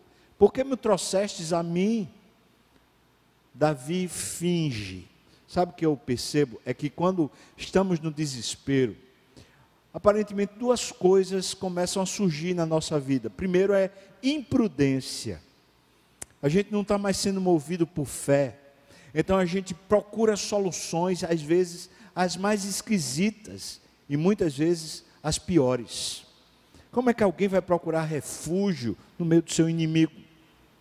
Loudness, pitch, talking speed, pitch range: -26 LUFS, 175 Hz, 130 wpm, 140-195 Hz